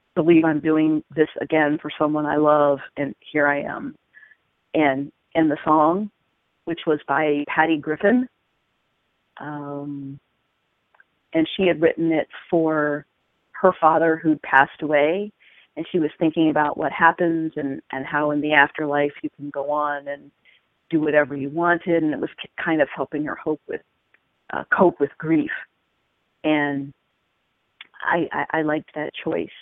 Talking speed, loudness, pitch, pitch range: 155 wpm, -21 LUFS, 155 Hz, 145-165 Hz